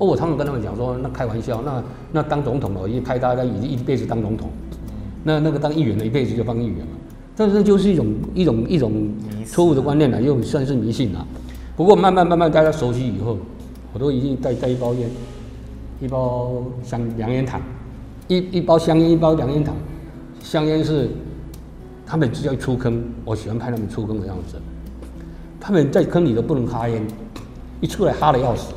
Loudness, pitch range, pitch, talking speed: -20 LUFS, 110-150 Hz, 125 Hz, 300 characters per minute